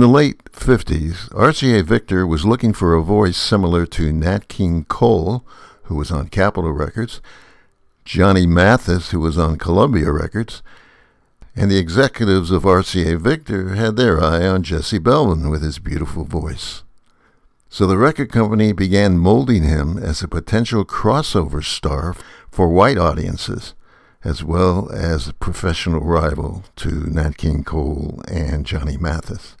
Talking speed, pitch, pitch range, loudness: 145 wpm, 90 Hz, 80-105 Hz, -17 LUFS